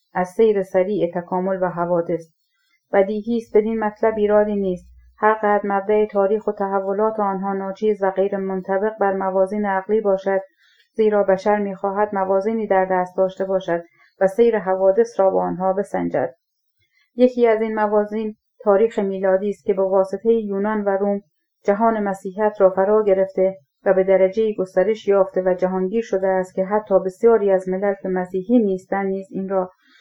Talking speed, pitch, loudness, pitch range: 165 wpm, 195 Hz, -20 LUFS, 190-210 Hz